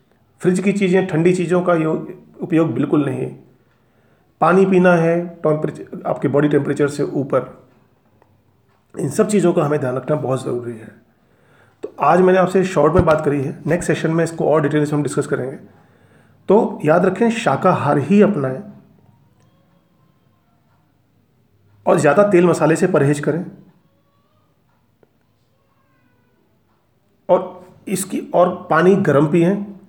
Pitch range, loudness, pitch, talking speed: 130-180 Hz, -17 LUFS, 150 Hz, 130 wpm